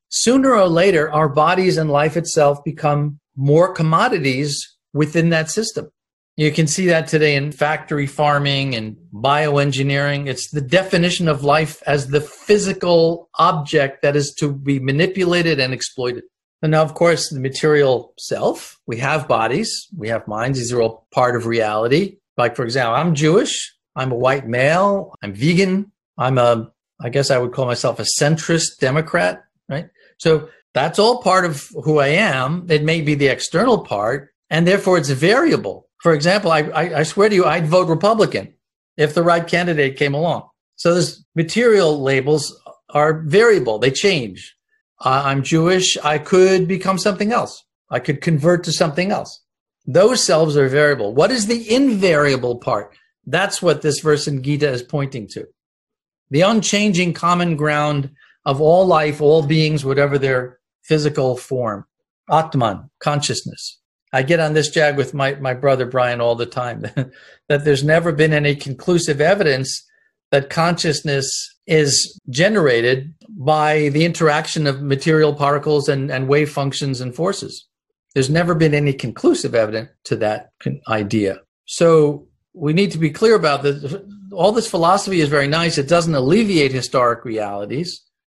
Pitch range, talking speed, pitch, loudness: 135-170 Hz, 160 wpm, 150 Hz, -17 LUFS